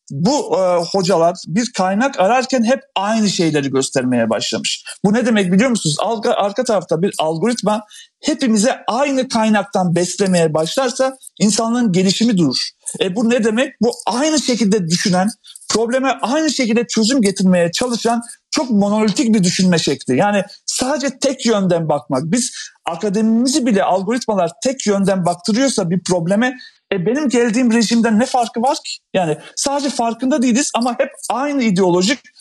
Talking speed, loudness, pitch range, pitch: 145 wpm, -16 LUFS, 190-255 Hz, 225 Hz